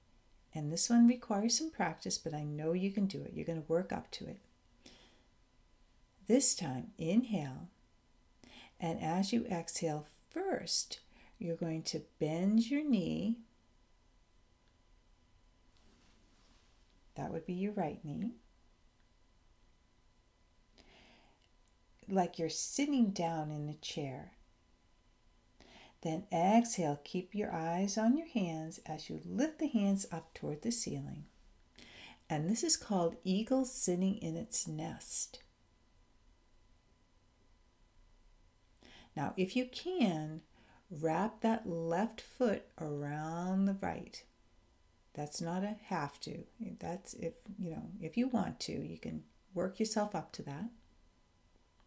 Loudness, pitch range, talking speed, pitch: -36 LUFS, 150-215 Hz, 120 wpm, 170 Hz